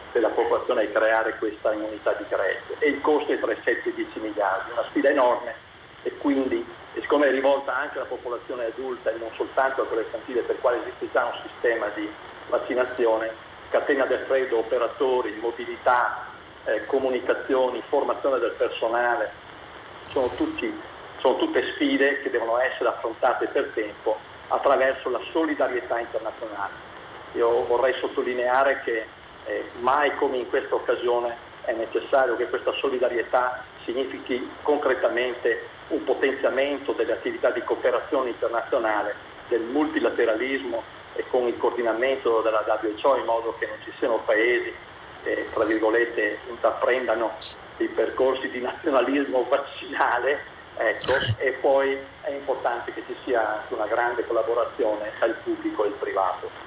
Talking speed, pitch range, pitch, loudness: 145 wpm, 280-470 Hz, 390 Hz, -25 LUFS